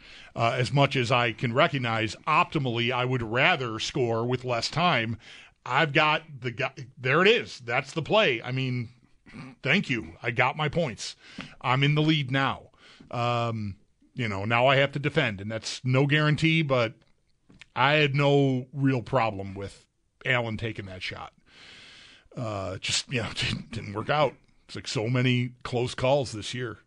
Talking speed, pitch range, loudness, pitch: 170 wpm, 115-145 Hz, -26 LUFS, 125 Hz